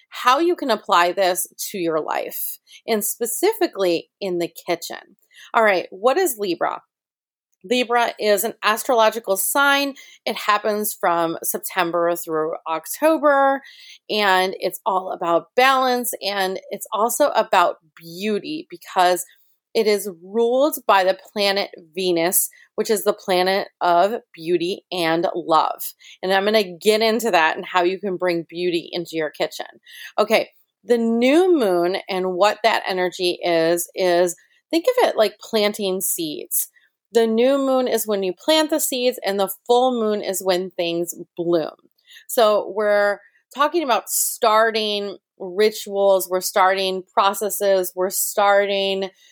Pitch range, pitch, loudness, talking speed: 180-235 Hz, 200 Hz, -20 LUFS, 140 wpm